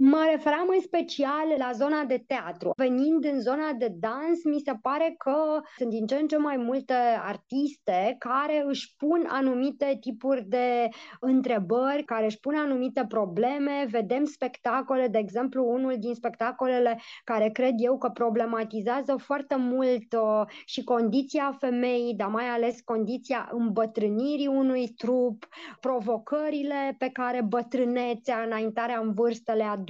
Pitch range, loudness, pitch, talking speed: 235-280 Hz, -27 LUFS, 255 Hz, 140 wpm